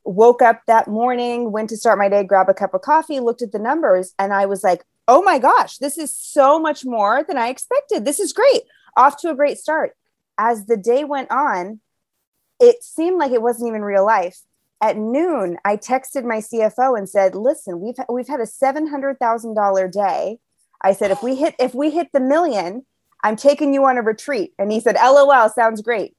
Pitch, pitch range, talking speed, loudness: 240 Hz, 215-285 Hz, 210 wpm, -17 LUFS